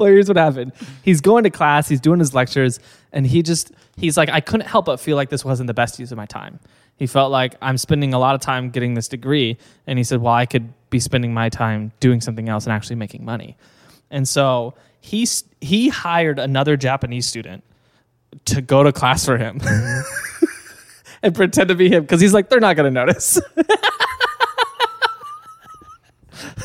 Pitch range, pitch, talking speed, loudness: 125-185 Hz, 135 Hz, 190 wpm, -17 LUFS